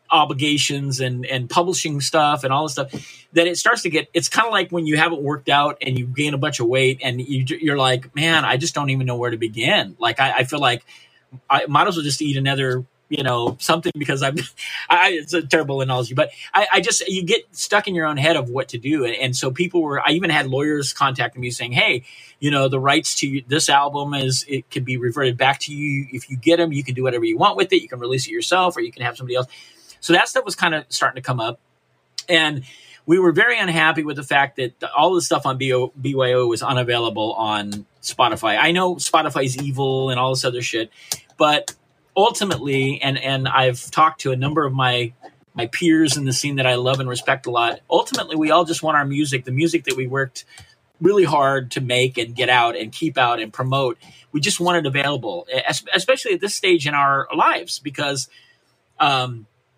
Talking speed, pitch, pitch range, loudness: 230 wpm, 140 Hz, 130-160 Hz, -19 LUFS